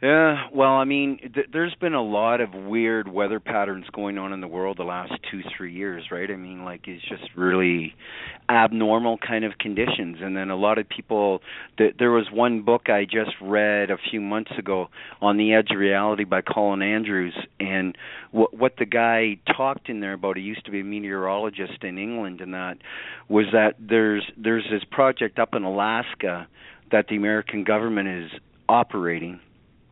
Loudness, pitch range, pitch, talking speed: -23 LUFS, 95-115 Hz, 105 Hz, 185 wpm